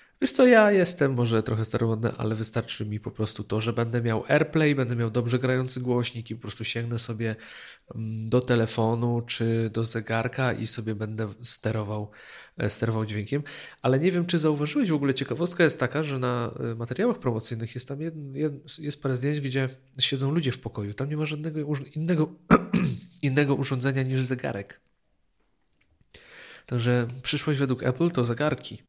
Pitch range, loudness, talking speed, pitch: 115-150 Hz, -26 LUFS, 165 wpm, 125 Hz